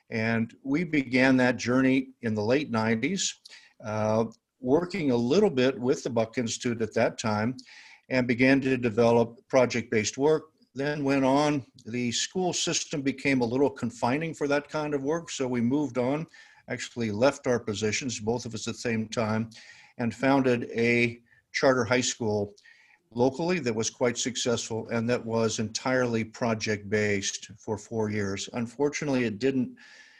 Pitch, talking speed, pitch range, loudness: 125 Hz, 160 wpm, 115-135 Hz, -27 LUFS